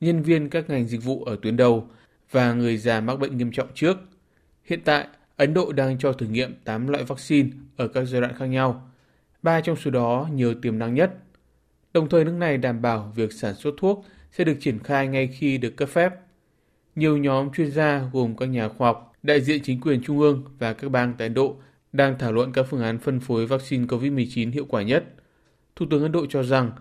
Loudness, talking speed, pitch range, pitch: -23 LUFS, 225 wpm, 120-145 Hz, 135 Hz